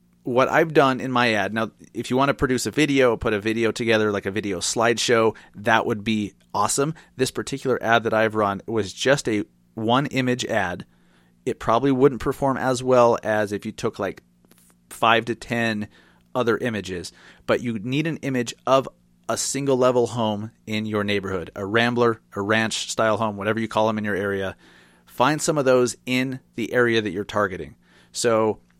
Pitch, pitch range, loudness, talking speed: 115 Hz, 105-125 Hz, -22 LUFS, 190 wpm